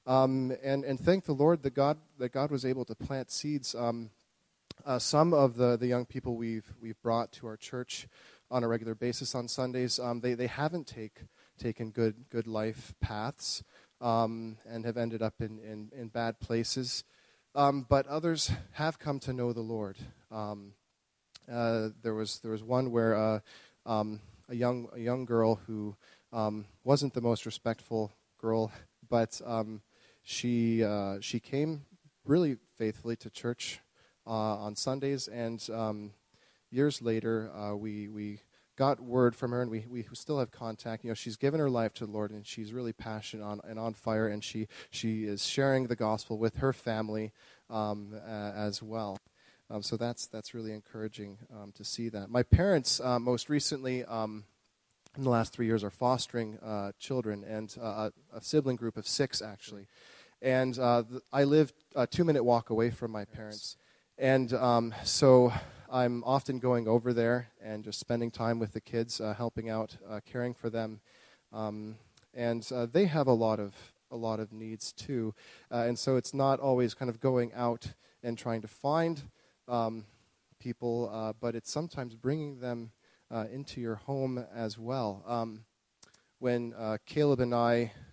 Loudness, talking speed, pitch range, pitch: -33 LUFS, 180 wpm, 110-125 Hz, 115 Hz